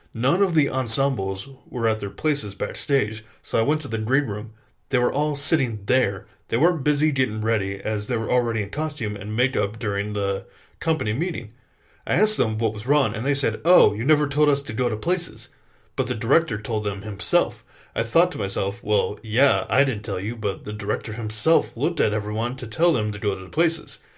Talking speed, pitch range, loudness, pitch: 215 wpm, 105-145 Hz, -23 LUFS, 115 Hz